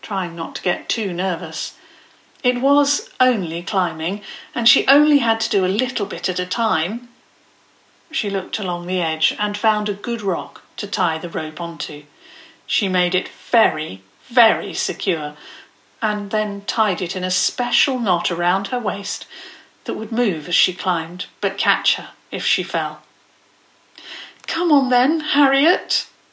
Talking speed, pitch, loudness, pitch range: 160 wpm, 205 Hz, -19 LUFS, 180-245 Hz